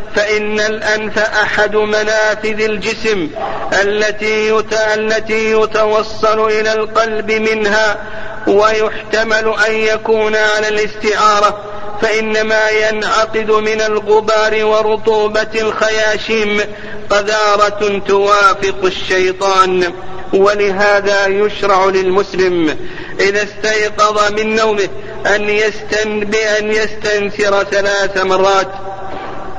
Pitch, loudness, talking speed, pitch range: 215 Hz, -13 LUFS, 70 wpm, 205-215 Hz